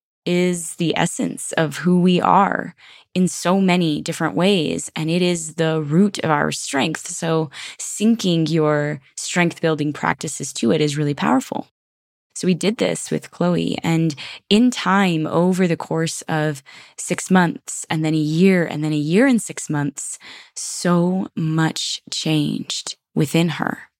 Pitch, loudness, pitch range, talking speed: 165 Hz, -20 LUFS, 155-185 Hz, 155 wpm